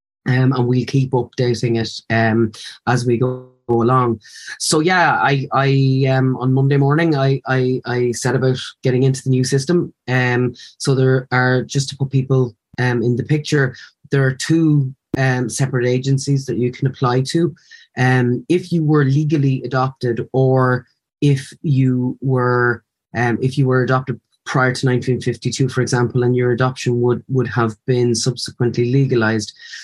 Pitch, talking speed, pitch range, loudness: 130 Hz, 165 wpm, 125-135 Hz, -17 LUFS